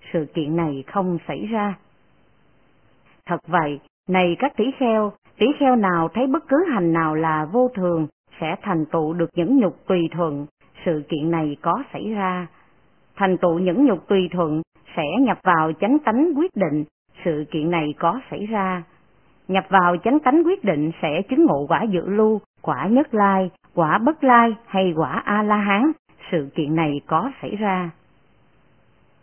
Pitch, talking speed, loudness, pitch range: 180 Hz, 175 wpm, -21 LUFS, 165-215 Hz